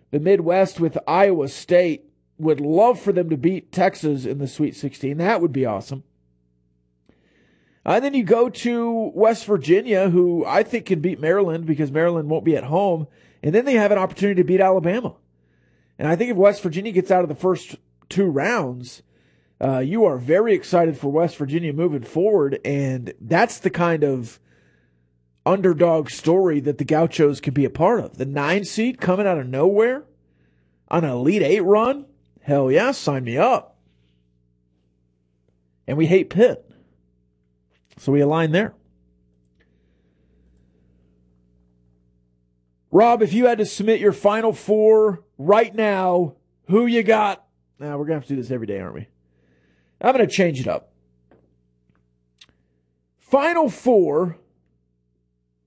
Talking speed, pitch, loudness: 155 wpm, 145 Hz, -20 LUFS